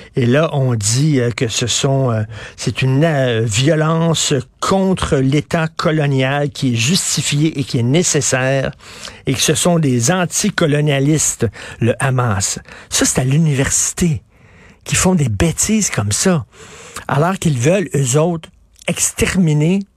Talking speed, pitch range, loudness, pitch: 130 wpm, 125-165 Hz, -15 LUFS, 140 Hz